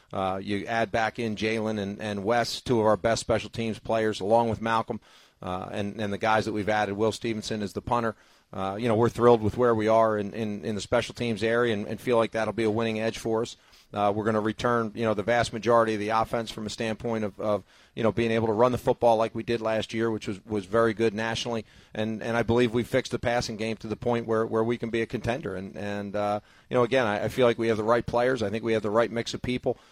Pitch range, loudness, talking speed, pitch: 105-115 Hz, -27 LUFS, 280 wpm, 110 Hz